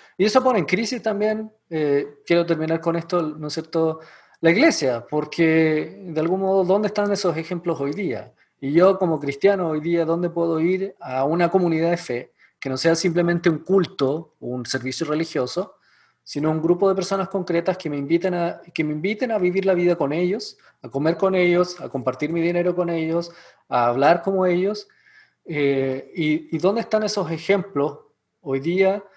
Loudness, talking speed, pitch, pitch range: -22 LUFS, 185 wpm, 170 Hz, 155-190 Hz